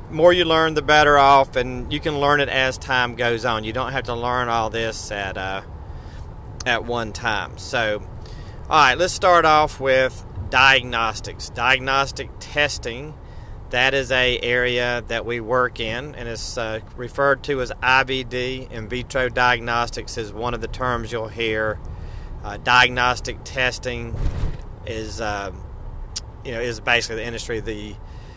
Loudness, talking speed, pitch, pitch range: -20 LUFS, 155 wpm, 120 Hz, 110-130 Hz